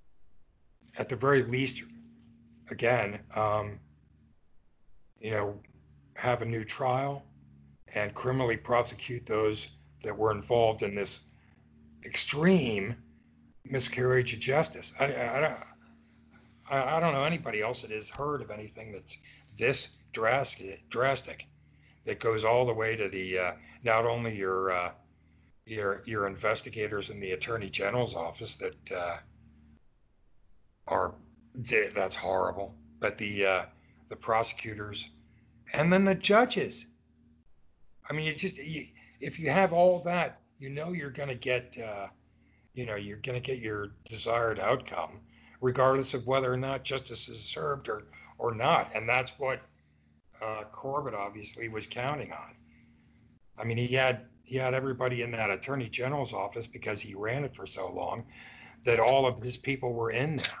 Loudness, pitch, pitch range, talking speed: -31 LUFS, 115 Hz, 95-130 Hz, 145 wpm